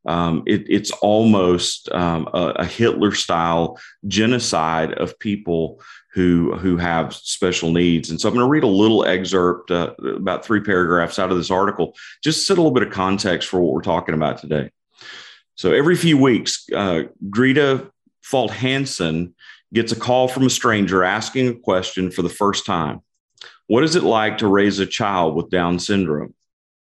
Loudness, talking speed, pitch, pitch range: -19 LUFS, 175 wpm, 95 Hz, 85-115 Hz